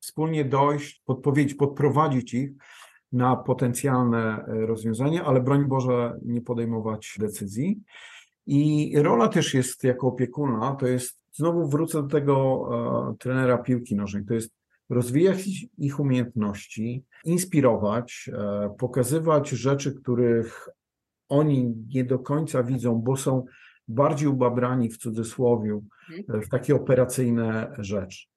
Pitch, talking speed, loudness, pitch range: 130 Hz, 115 wpm, -25 LUFS, 115-145 Hz